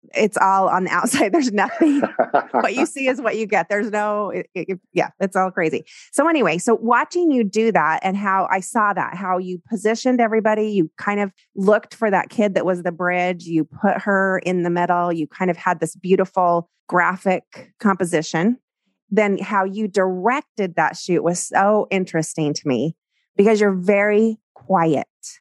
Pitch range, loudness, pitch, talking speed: 180-215 Hz, -19 LUFS, 195 Hz, 185 wpm